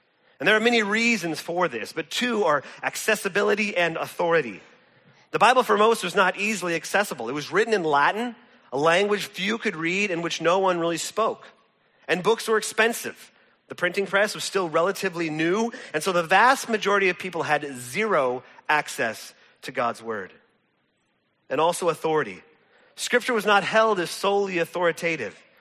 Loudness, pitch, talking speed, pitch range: -23 LUFS, 190 Hz, 165 wpm, 165-220 Hz